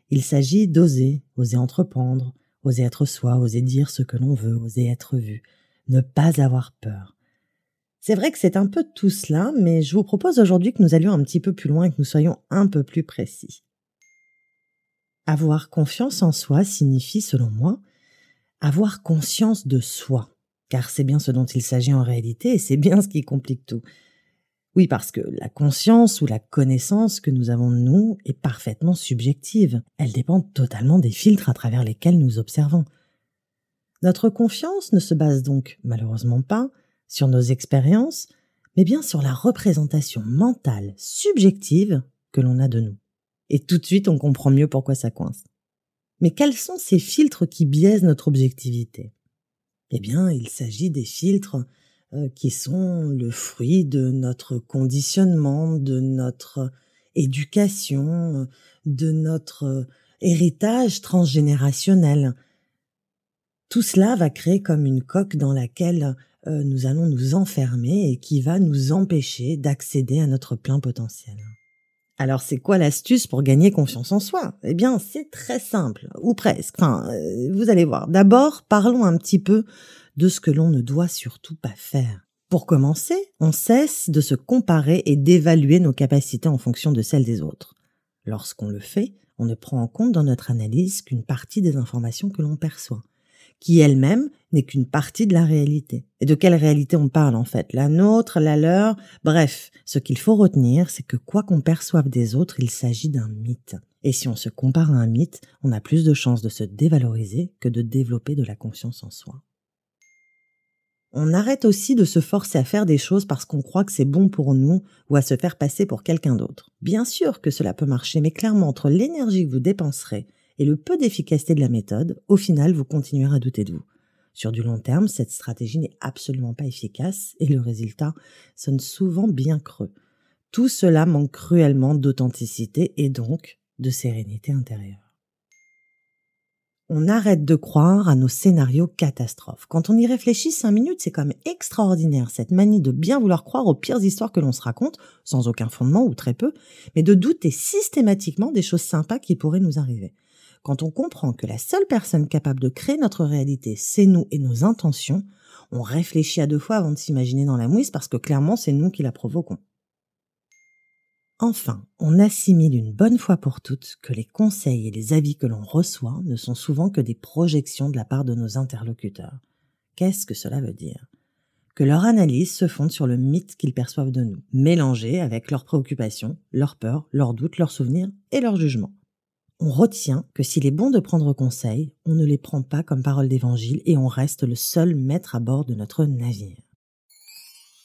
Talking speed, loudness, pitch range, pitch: 180 wpm, -20 LUFS, 130-185 Hz, 150 Hz